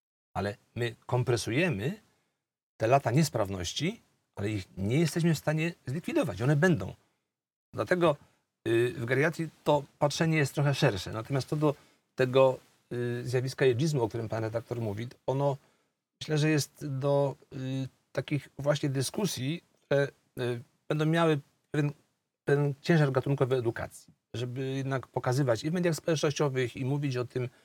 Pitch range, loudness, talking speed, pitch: 125-150 Hz, -30 LUFS, 130 wpm, 135 Hz